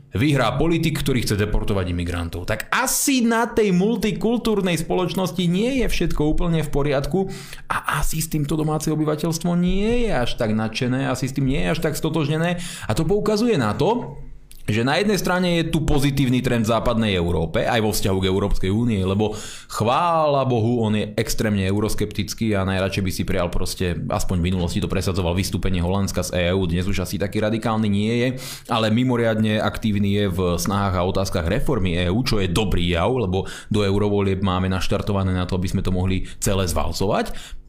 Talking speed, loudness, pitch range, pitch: 180 wpm, -21 LUFS, 95-155 Hz, 110 Hz